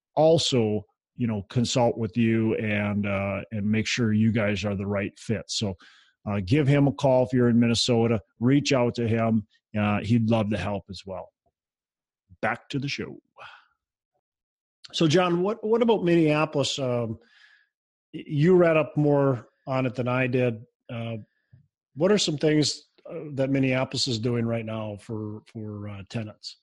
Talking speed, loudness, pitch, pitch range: 165 wpm, -25 LUFS, 120 Hz, 110-140 Hz